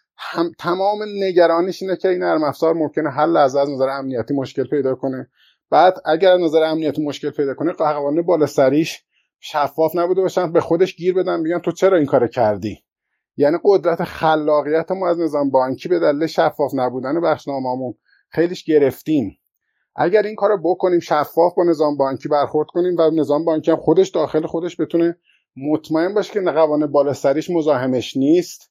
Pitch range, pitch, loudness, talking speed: 145-175 Hz, 160 Hz, -18 LUFS, 170 wpm